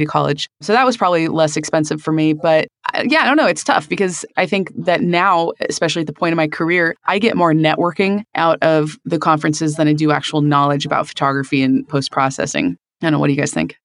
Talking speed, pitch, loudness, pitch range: 245 wpm, 160 Hz, -16 LUFS, 150-175 Hz